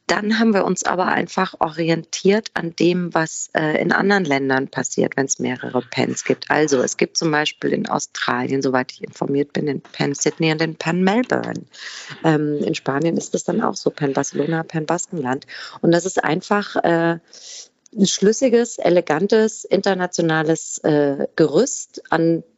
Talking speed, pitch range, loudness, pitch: 165 wpm, 150-195 Hz, -20 LUFS, 165 Hz